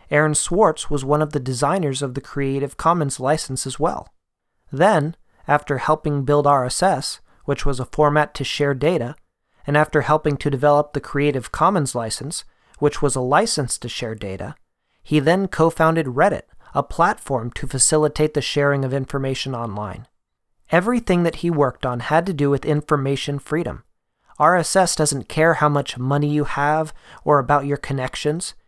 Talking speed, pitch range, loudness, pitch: 165 wpm, 135-155 Hz, -20 LUFS, 145 Hz